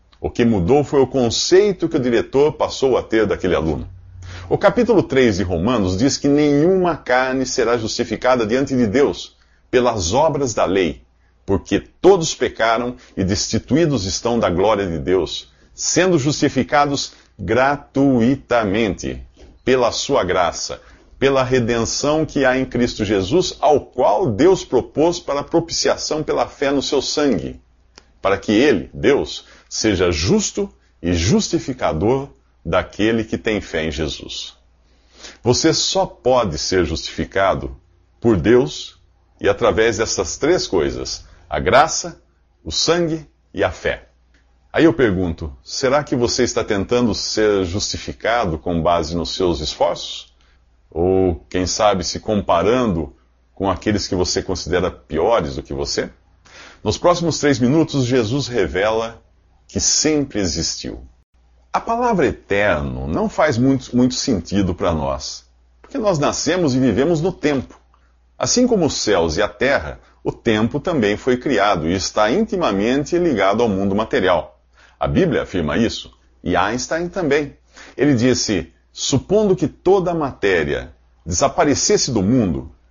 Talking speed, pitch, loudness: 140 wpm, 115 Hz, -18 LUFS